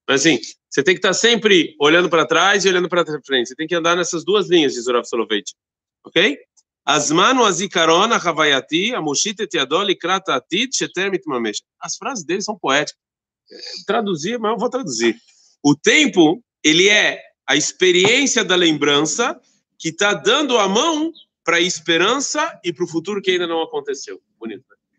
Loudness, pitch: -17 LUFS, 205 Hz